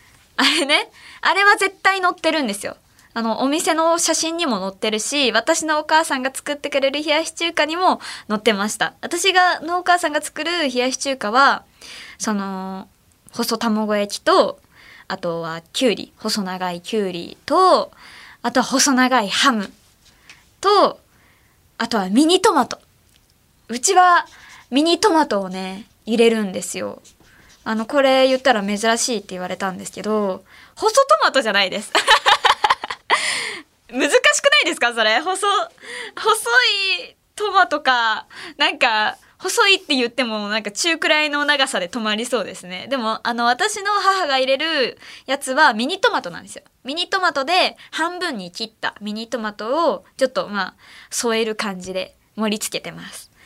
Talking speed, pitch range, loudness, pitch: 300 characters per minute, 220-335 Hz, -18 LUFS, 270 Hz